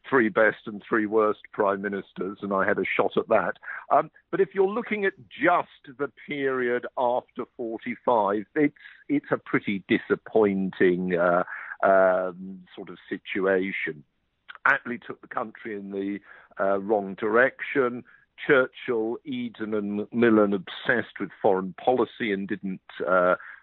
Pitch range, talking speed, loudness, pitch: 95-135 Hz, 140 wpm, -25 LUFS, 105 Hz